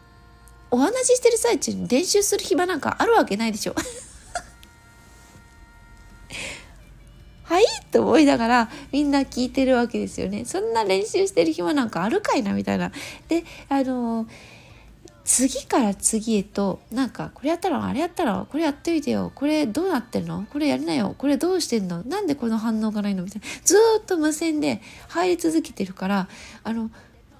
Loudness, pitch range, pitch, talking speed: -22 LUFS, 210-335 Hz, 270 Hz, 345 characters per minute